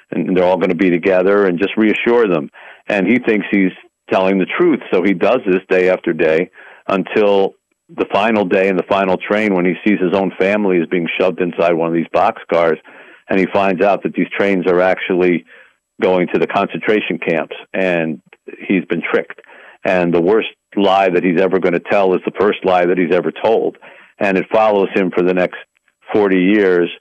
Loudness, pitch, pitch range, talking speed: -15 LUFS, 90 Hz, 90-100 Hz, 205 wpm